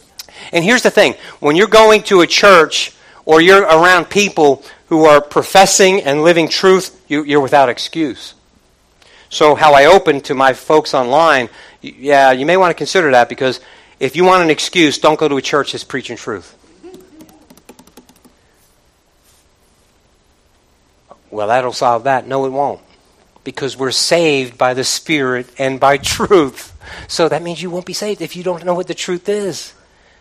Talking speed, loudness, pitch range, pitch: 165 wpm, -12 LUFS, 135-180 Hz, 155 Hz